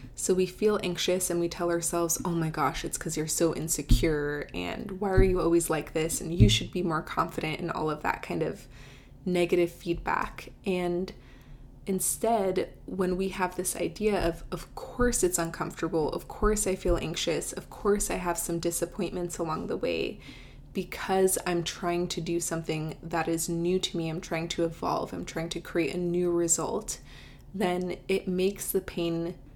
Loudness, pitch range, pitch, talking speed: -29 LUFS, 165-185 Hz, 170 Hz, 185 wpm